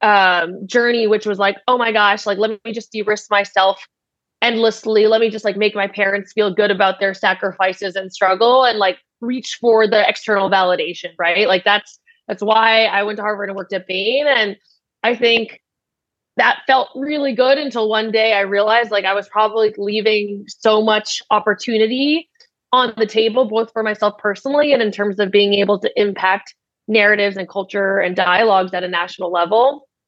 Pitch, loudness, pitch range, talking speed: 210 Hz, -16 LUFS, 195-225 Hz, 185 wpm